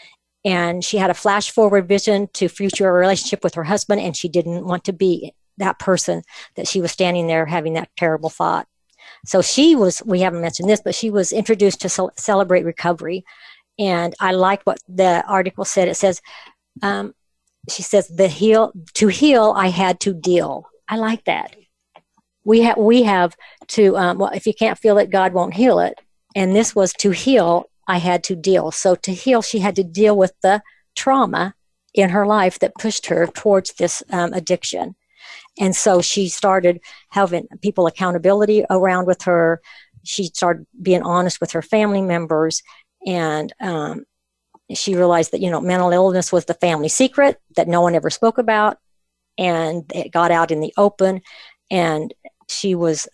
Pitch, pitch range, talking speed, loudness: 185 Hz, 175-205 Hz, 180 wpm, -18 LUFS